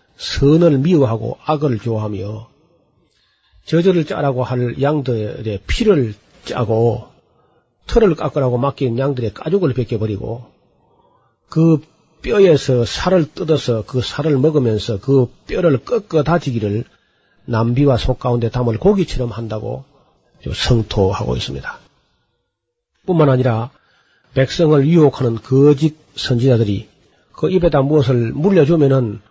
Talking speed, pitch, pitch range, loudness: 255 characters per minute, 130 Hz, 115-155 Hz, -16 LUFS